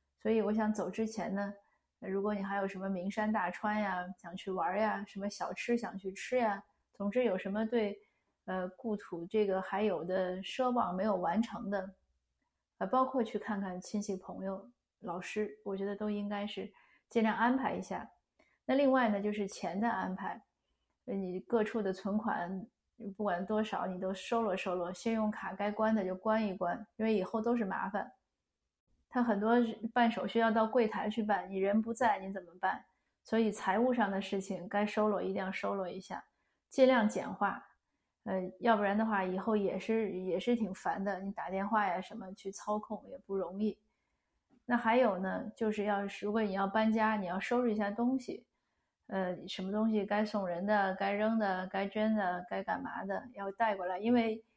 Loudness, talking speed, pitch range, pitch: -34 LUFS, 265 characters per minute, 190-225 Hz, 205 Hz